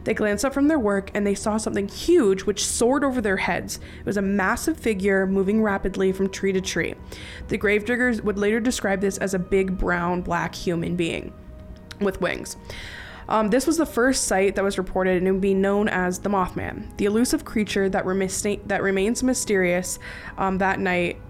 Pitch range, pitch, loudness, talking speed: 185-215 Hz, 195 Hz, -23 LUFS, 195 wpm